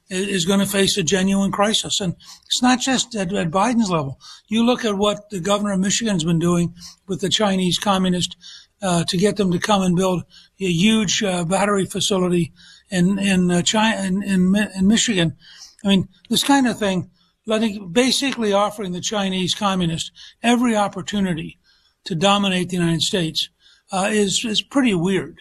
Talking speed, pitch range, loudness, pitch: 175 wpm, 180-210 Hz, -19 LUFS, 195 Hz